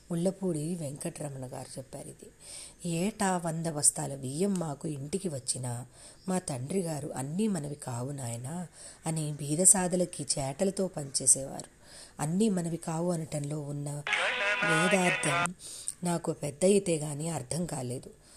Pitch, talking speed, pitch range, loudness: 160 Hz, 115 wpm, 145-180 Hz, -30 LUFS